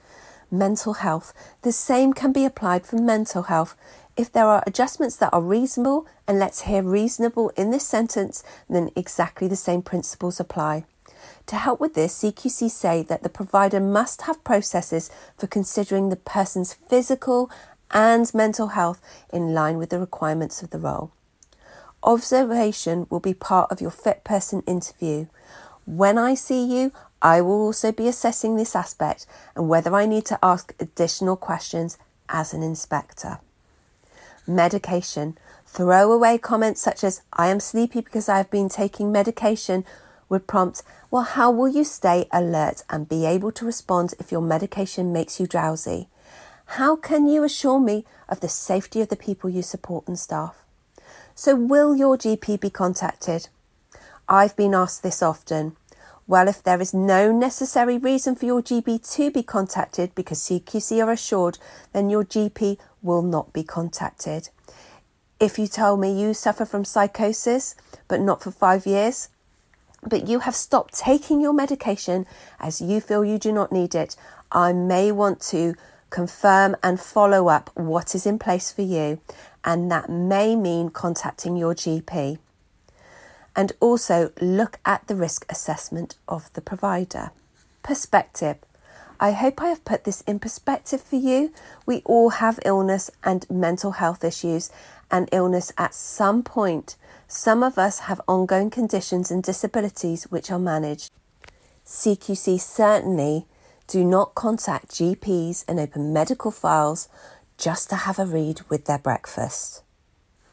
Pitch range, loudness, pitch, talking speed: 175-225 Hz, -22 LUFS, 195 Hz, 155 wpm